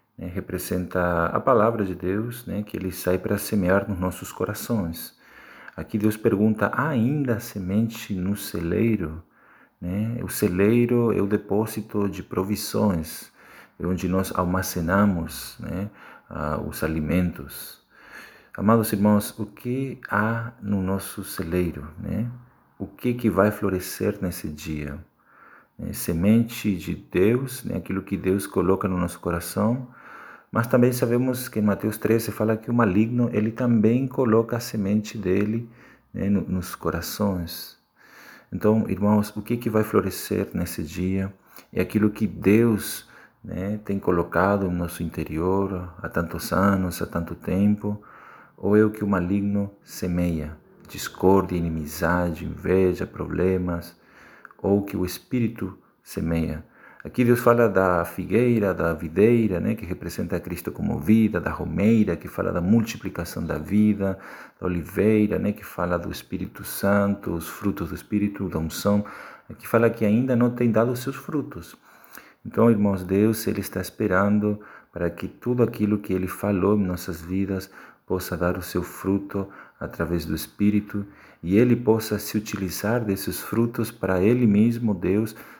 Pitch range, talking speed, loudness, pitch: 90-110 Hz, 145 wpm, -24 LUFS, 100 Hz